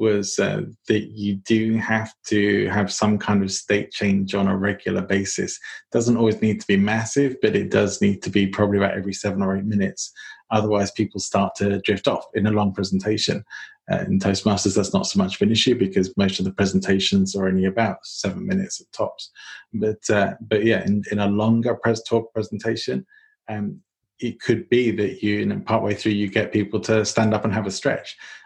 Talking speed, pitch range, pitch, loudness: 210 wpm, 100-110 Hz, 105 Hz, -22 LUFS